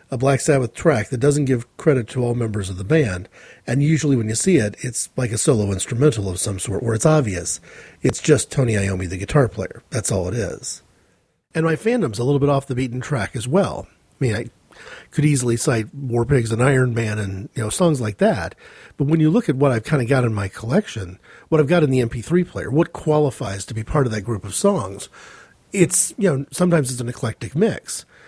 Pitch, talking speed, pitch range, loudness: 130 Hz, 230 wpm, 110-150 Hz, -20 LUFS